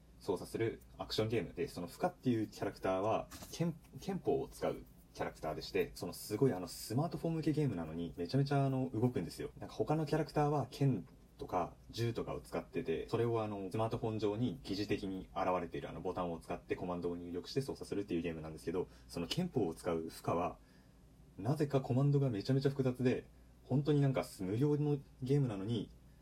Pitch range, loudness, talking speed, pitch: 90-140 Hz, -38 LUFS, 460 characters per minute, 120 Hz